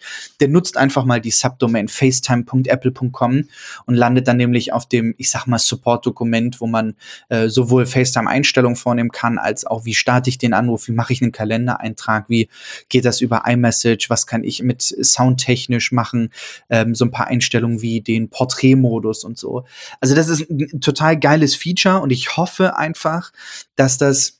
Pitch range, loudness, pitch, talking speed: 115-130 Hz, -16 LUFS, 125 Hz, 175 wpm